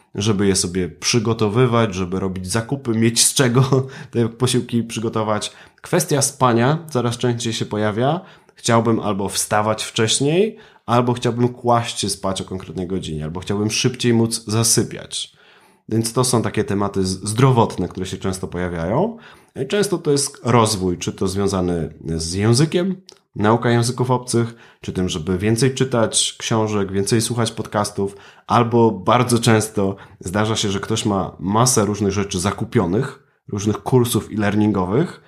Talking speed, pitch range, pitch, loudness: 140 wpm, 100-120 Hz, 110 Hz, -19 LUFS